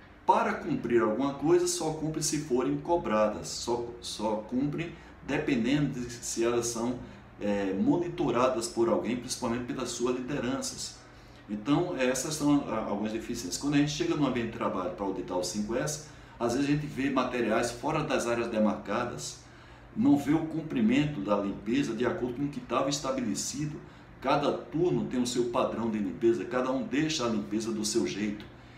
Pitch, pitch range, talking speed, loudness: 120 Hz, 110-145 Hz, 170 wpm, -30 LUFS